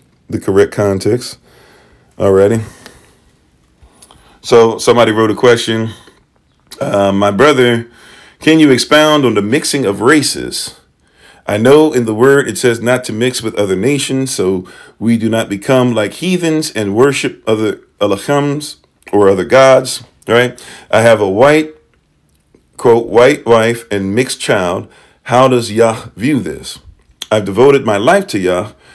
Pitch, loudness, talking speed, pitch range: 115 Hz, -11 LUFS, 145 wpm, 100-130 Hz